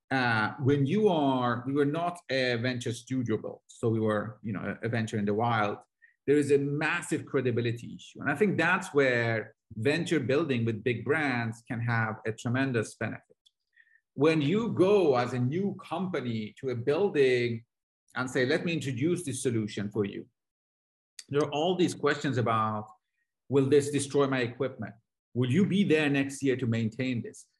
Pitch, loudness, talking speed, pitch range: 130 Hz, -29 LUFS, 175 wpm, 115-145 Hz